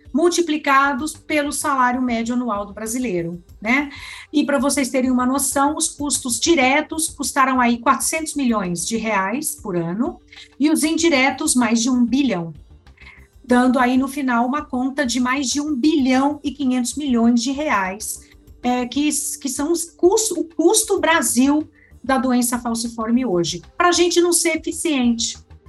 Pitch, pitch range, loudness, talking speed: 270 Hz, 240-300 Hz, -19 LUFS, 155 wpm